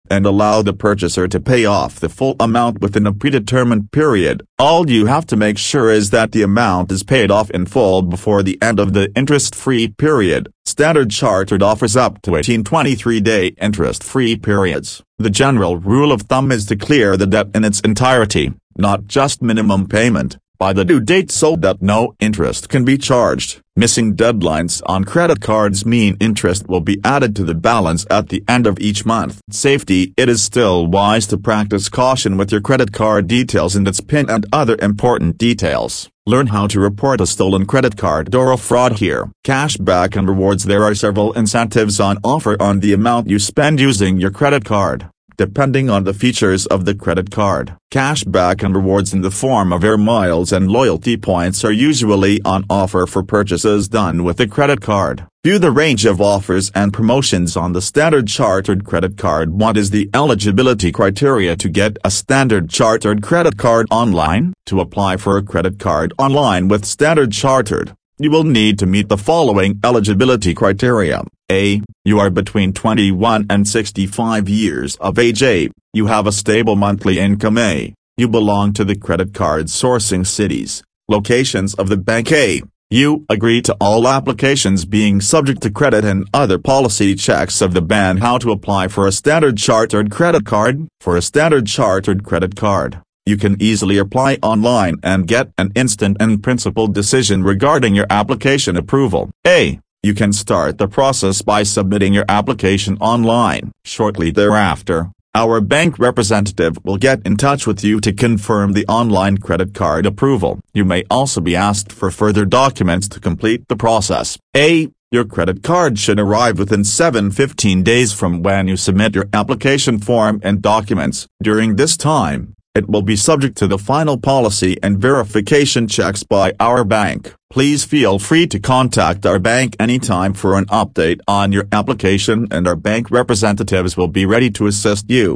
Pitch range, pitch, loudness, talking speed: 95-120 Hz, 105 Hz, -14 LUFS, 175 wpm